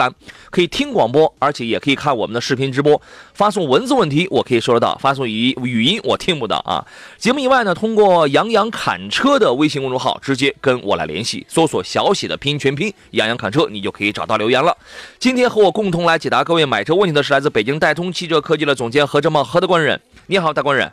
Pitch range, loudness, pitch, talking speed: 135-185 Hz, -16 LUFS, 150 Hz, 365 characters per minute